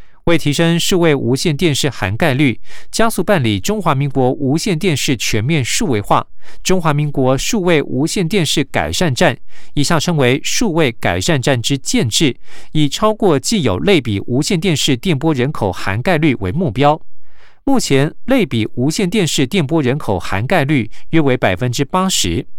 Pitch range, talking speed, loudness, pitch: 130-180 Hz, 260 characters per minute, -15 LUFS, 150 Hz